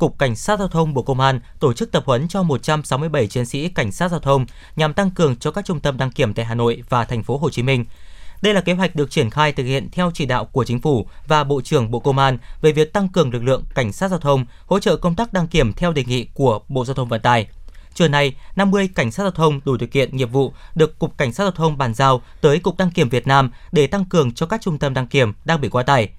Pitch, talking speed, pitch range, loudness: 140 Hz, 280 wpm, 125-165 Hz, -19 LUFS